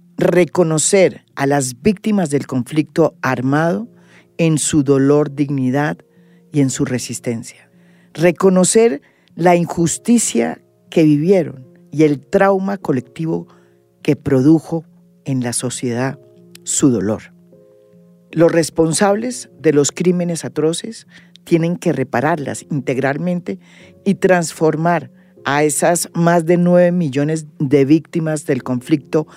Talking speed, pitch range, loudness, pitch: 110 wpm, 135-175 Hz, -16 LUFS, 155 Hz